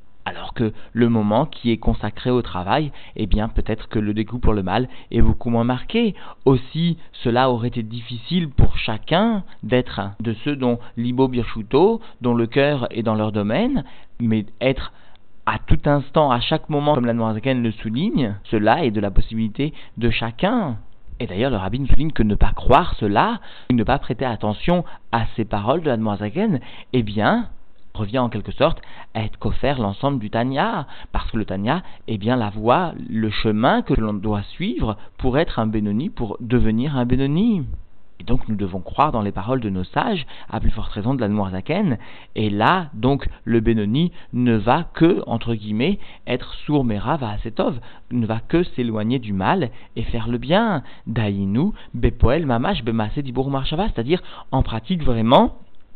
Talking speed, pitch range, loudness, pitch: 180 wpm, 110-135 Hz, -21 LUFS, 115 Hz